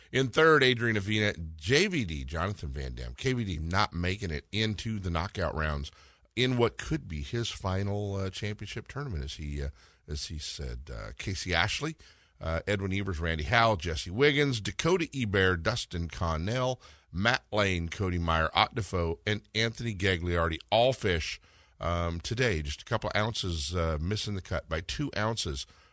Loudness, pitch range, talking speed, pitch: -30 LUFS, 80-110 Hz, 155 wpm, 95 Hz